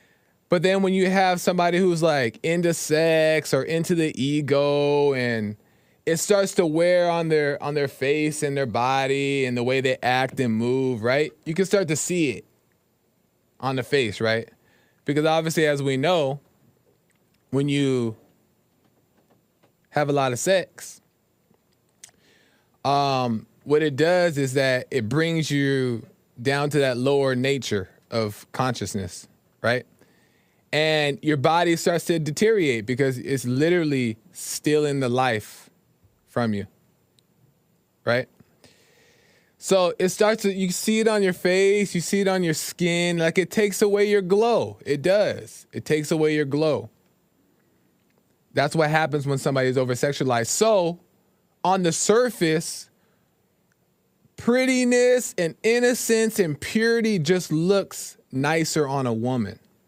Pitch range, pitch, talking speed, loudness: 130-180 Hz, 150 Hz, 140 wpm, -22 LUFS